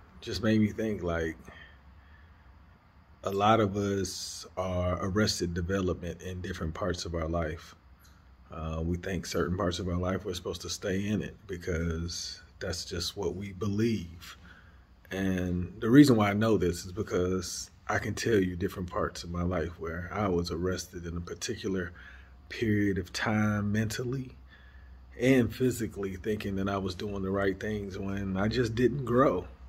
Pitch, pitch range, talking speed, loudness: 90 Hz, 85-100 Hz, 165 wpm, -31 LUFS